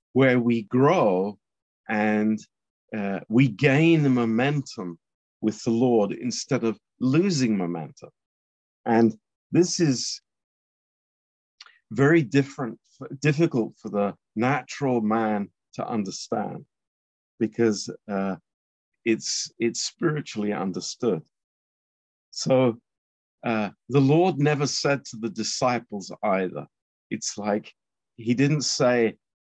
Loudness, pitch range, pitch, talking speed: -24 LUFS, 105-140 Hz, 115 Hz, 100 wpm